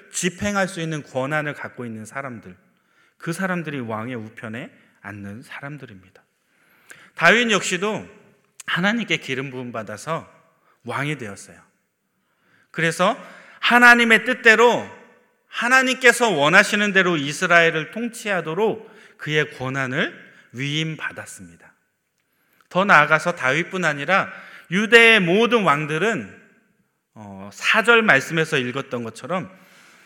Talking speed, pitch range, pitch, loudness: 260 characters per minute, 130-205 Hz, 160 Hz, -18 LUFS